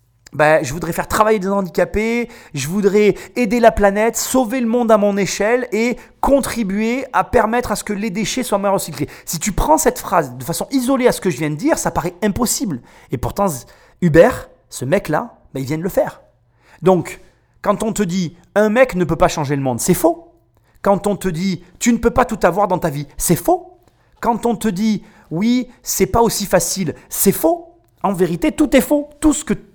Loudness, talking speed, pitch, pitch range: -17 LUFS, 220 wpm, 205 Hz, 175-235 Hz